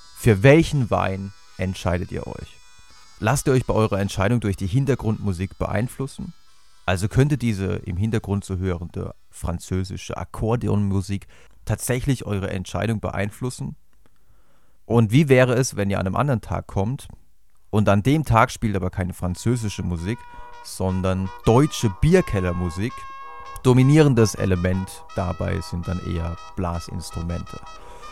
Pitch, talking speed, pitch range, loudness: 100 Hz, 125 wpm, 90-120 Hz, -22 LUFS